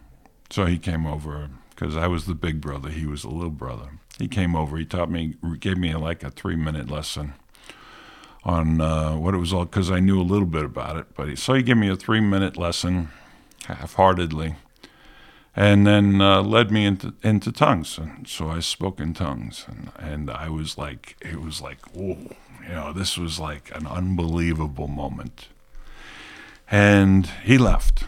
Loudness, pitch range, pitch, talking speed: -23 LUFS, 75-95 Hz, 85 Hz, 180 wpm